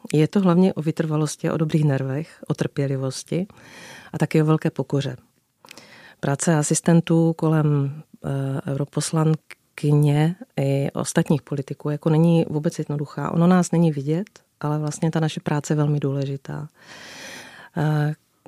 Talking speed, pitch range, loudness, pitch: 130 wpm, 145-165 Hz, -22 LUFS, 155 Hz